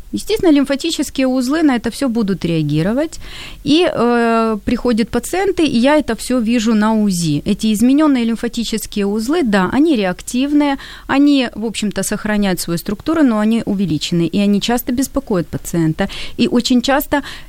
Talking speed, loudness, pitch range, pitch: 150 wpm, -16 LUFS, 205-275 Hz, 235 Hz